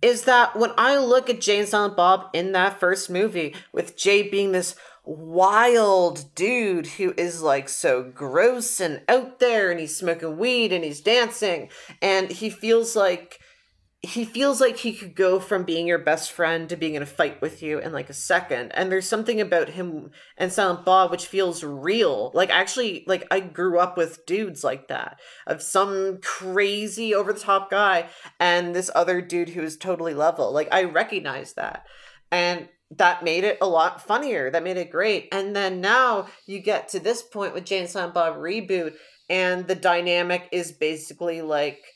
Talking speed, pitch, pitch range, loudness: 185 wpm, 185 Hz, 170-210 Hz, -22 LUFS